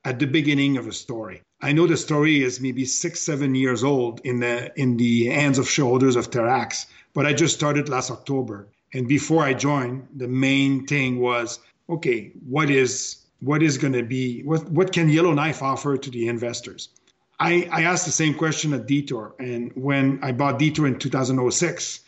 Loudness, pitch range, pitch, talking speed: -22 LUFS, 125-150 Hz, 135 Hz, 200 wpm